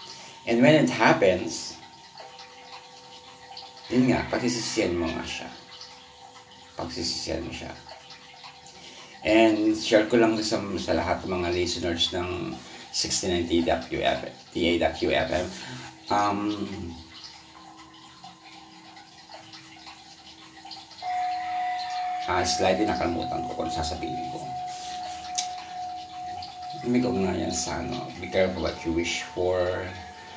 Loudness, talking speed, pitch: -26 LUFS, 90 wpm, 105 Hz